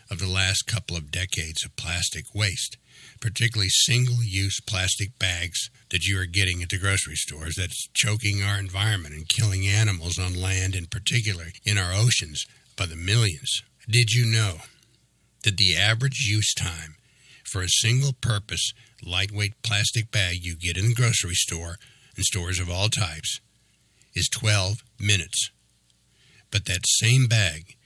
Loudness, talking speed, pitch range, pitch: -24 LUFS, 155 wpm, 90-115 Hz, 105 Hz